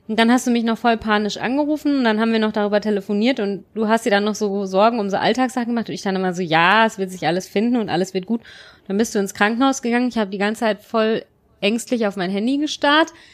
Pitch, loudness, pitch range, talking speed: 220 Hz, -19 LUFS, 200-235 Hz, 270 wpm